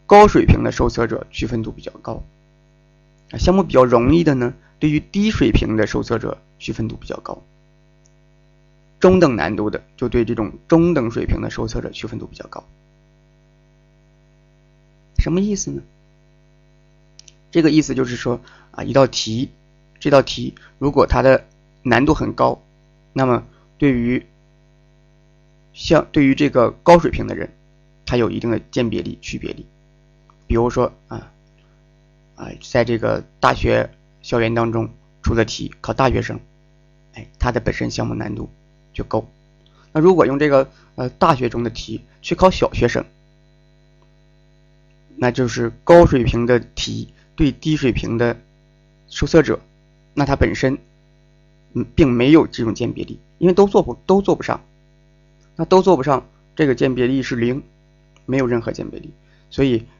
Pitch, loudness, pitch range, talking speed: 155 Hz, -18 LUFS, 125-160 Hz, 220 characters per minute